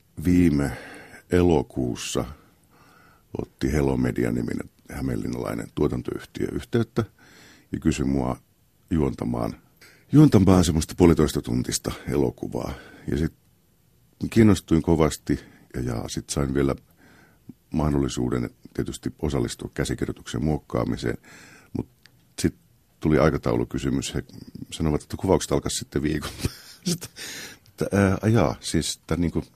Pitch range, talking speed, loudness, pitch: 70-90 Hz, 95 wpm, -25 LUFS, 80 Hz